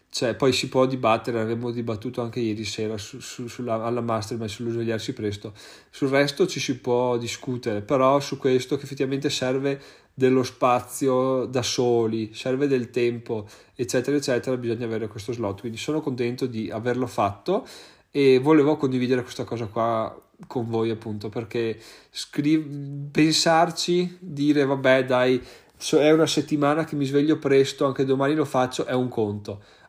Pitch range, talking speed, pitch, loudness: 115-140 Hz, 160 wpm, 125 Hz, -24 LUFS